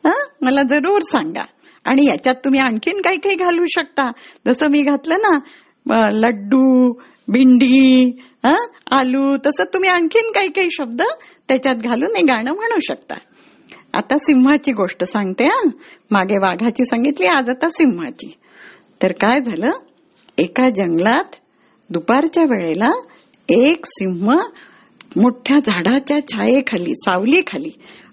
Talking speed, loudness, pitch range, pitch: 120 wpm, -16 LUFS, 245-325 Hz, 275 Hz